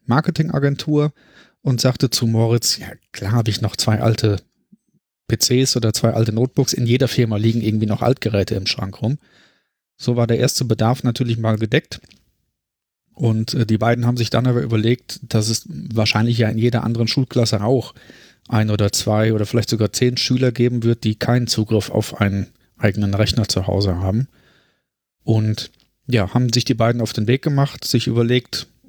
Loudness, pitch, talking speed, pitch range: -19 LUFS, 115 Hz, 175 wpm, 110-125 Hz